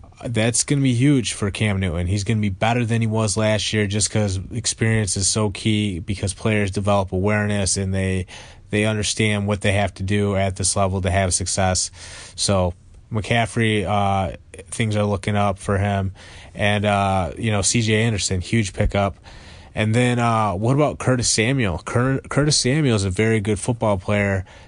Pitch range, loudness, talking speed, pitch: 95-110 Hz, -20 LUFS, 185 wpm, 105 Hz